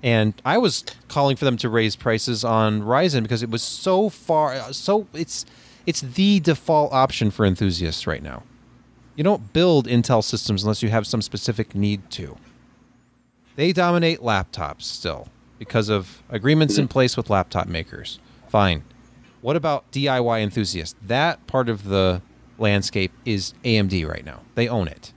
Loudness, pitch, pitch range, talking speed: -21 LUFS, 115 Hz, 105-140 Hz, 160 wpm